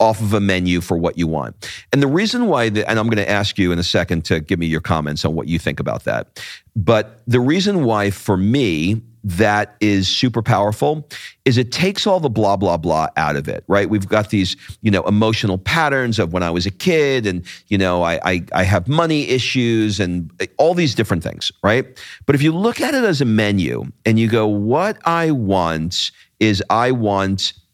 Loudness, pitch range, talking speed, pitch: -17 LUFS, 95-125 Hz, 220 wpm, 105 Hz